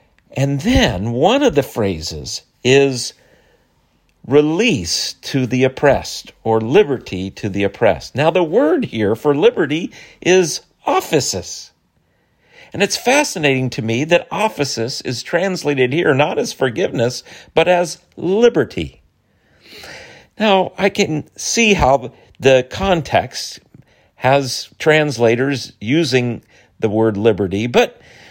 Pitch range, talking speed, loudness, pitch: 115-175 Hz, 115 wpm, -16 LUFS, 135 Hz